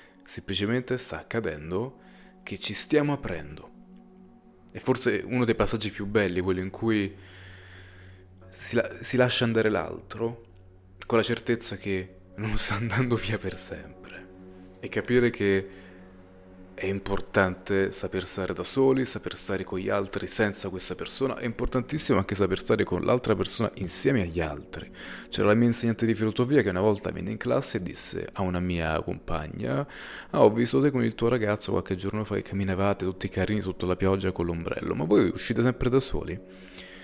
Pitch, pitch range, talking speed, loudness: 100 Hz, 95-115 Hz, 170 wpm, -27 LUFS